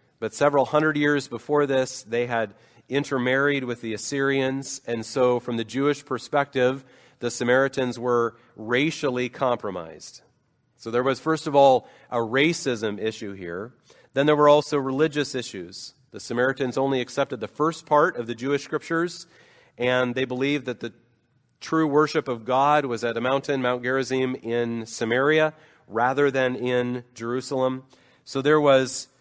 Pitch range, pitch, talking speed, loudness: 120-145 Hz, 130 Hz, 150 wpm, -24 LUFS